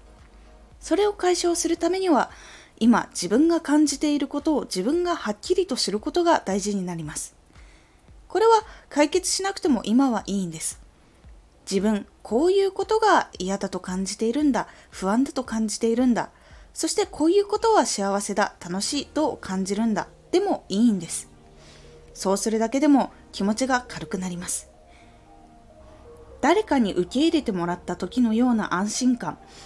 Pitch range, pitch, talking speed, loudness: 190-320 Hz, 230 Hz, 320 characters per minute, -23 LUFS